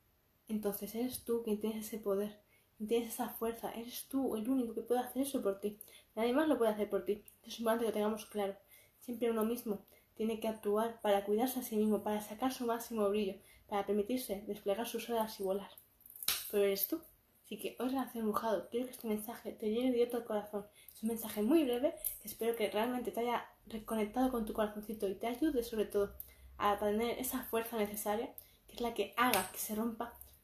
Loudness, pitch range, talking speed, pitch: -37 LUFS, 205-235 Hz, 215 wpm, 225 Hz